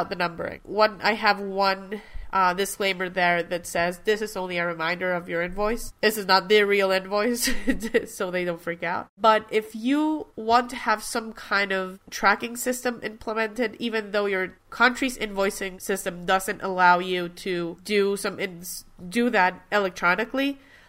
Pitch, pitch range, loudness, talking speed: 200 Hz, 185-225 Hz, -24 LUFS, 165 wpm